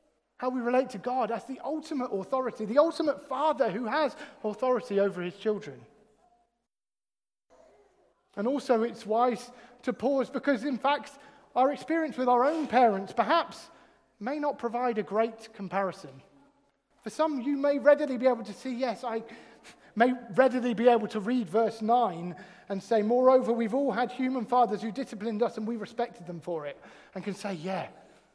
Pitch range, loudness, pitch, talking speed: 220-265 Hz, -29 LUFS, 240 Hz, 170 wpm